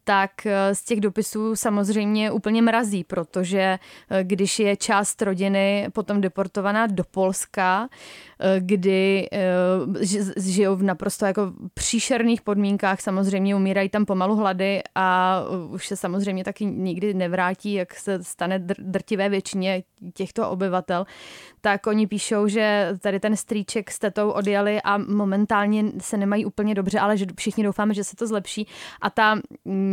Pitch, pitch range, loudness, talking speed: 200 Hz, 190-210 Hz, -23 LUFS, 135 wpm